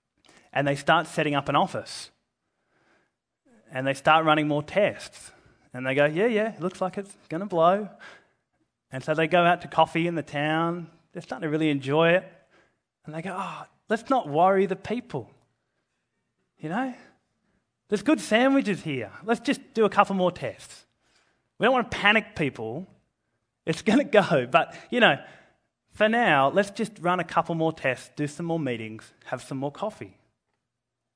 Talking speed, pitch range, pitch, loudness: 175 wpm, 145-200 Hz, 165 Hz, -25 LUFS